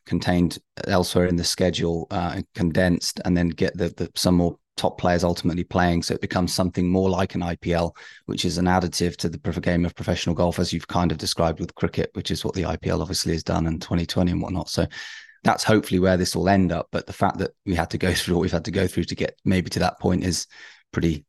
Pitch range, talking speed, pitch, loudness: 85-95 Hz, 240 wpm, 90 Hz, -23 LUFS